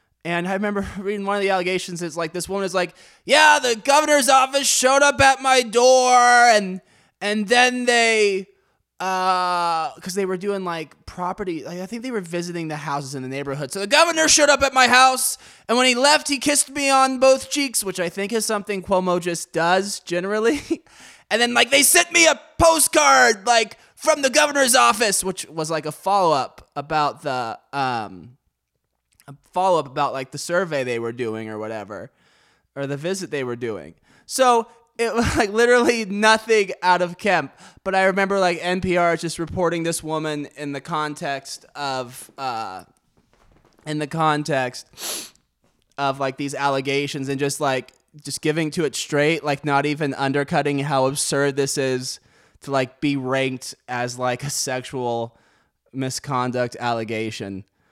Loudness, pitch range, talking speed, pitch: -20 LUFS, 140-235 Hz, 175 wpm, 180 Hz